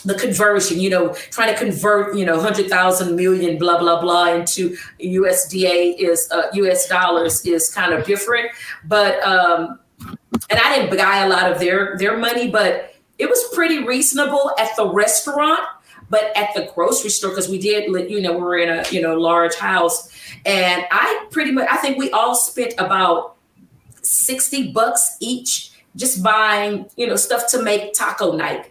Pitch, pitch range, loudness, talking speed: 200 Hz, 180-240 Hz, -17 LUFS, 180 wpm